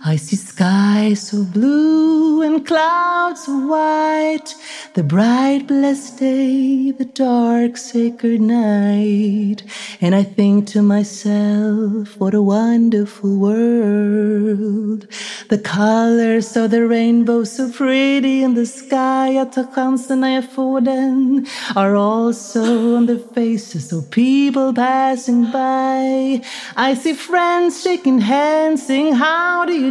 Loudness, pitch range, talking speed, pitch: -16 LUFS, 210-270 Hz, 120 wpm, 240 Hz